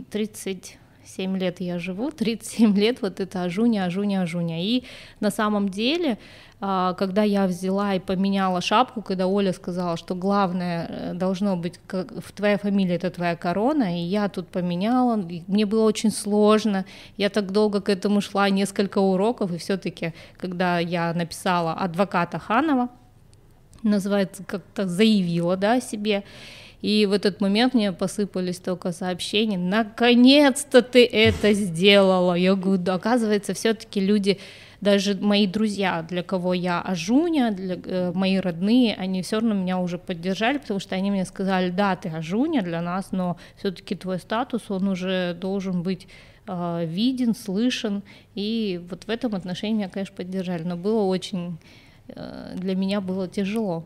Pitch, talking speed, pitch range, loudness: 195 Hz, 150 wpm, 185-215 Hz, -23 LUFS